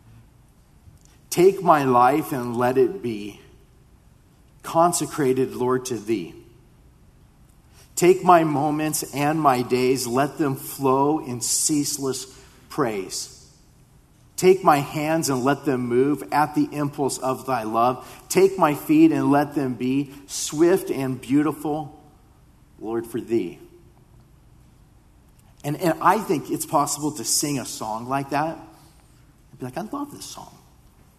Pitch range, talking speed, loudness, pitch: 130-155 Hz, 130 wpm, -22 LUFS, 140 Hz